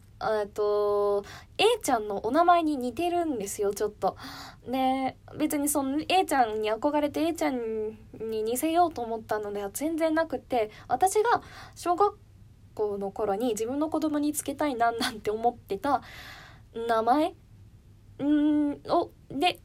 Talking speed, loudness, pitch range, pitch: 260 characters per minute, -28 LUFS, 215-315 Hz, 255 Hz